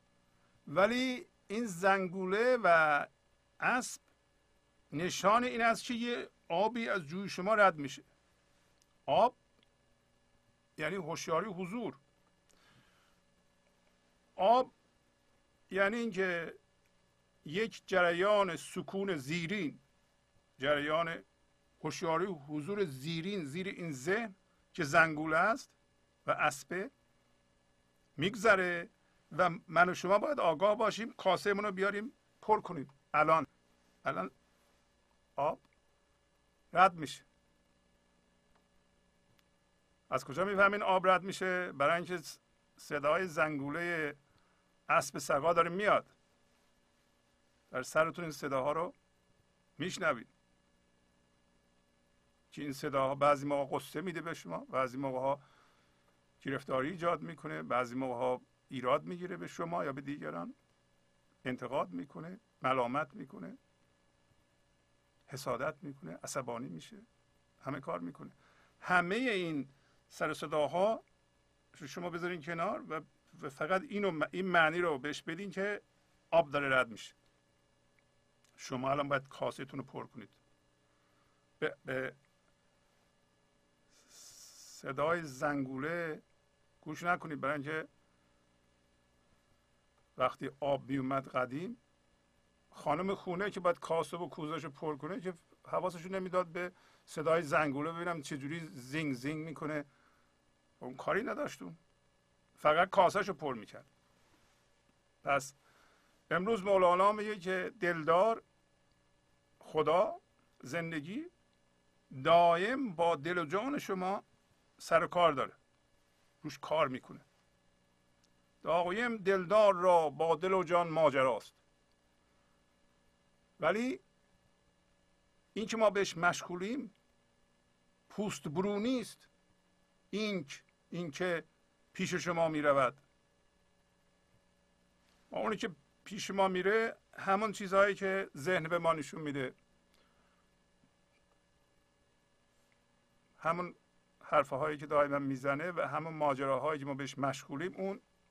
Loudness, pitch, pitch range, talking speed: -34 LUFS, 155 Hz, 115-185 Hz, 100 wpm